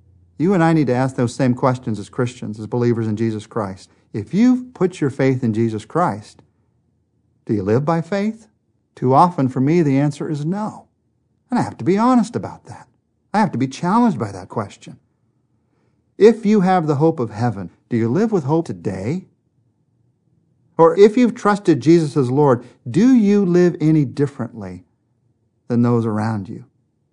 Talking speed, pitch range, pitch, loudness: 180 wpm, 115-165 Hz, 130 Hz, -18 LUFS